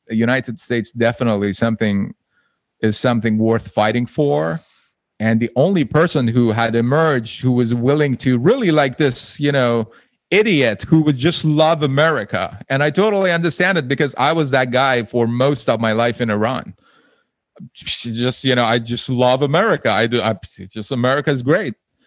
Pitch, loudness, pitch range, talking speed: 125 Hz, -17 LUFS, 115-145 Hz, 175 wpm